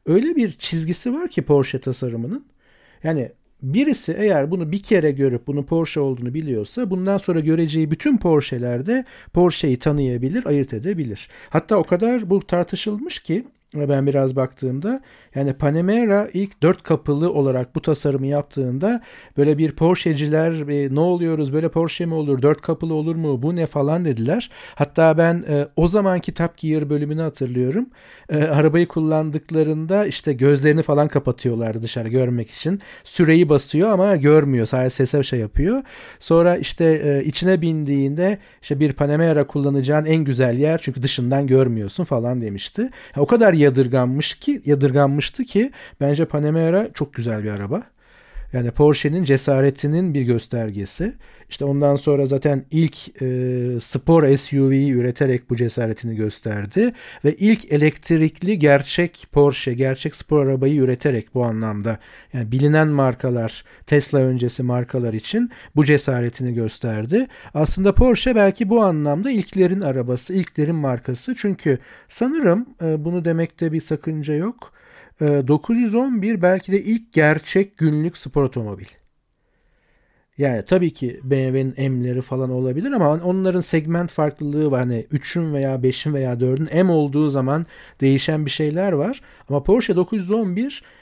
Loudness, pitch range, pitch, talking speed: -19 LUFS, 135-180 Hz, 150 Hz, 135 wpm